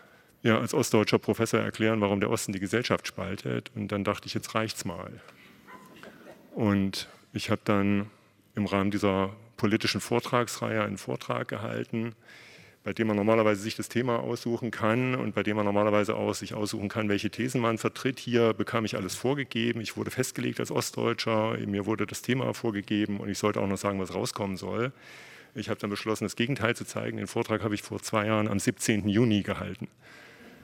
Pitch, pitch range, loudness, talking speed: 105 Hz, 100-115 Hz, -29 LUFS, 190 wpm